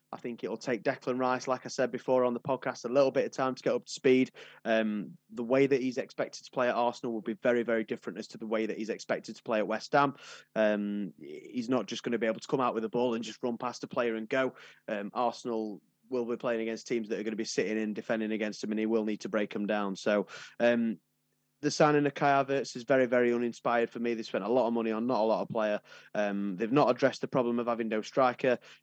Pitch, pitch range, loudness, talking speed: 120 Hz, 110-130 Hz, -31 LUFS, 275 wpm